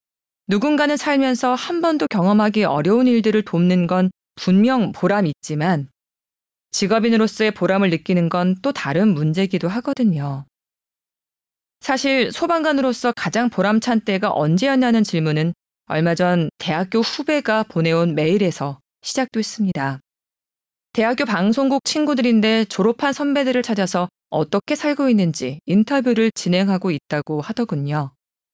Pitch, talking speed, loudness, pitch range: 205 Hz, 305 characters per minute, -19 LUFS, 170-245 Hz